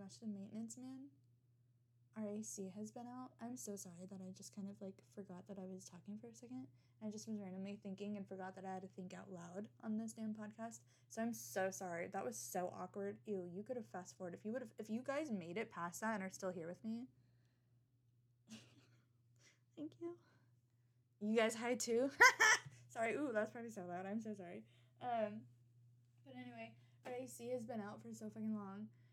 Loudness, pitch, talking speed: -43 LUFS, 190 Hz, 205 wpm